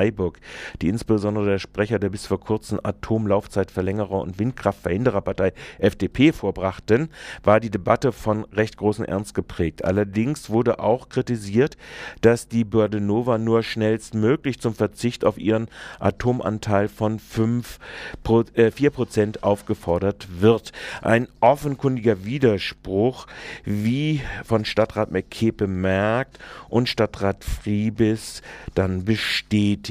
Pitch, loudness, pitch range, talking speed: 110 Hz, -22 LUFS, 100-115 Hz, 105 wpm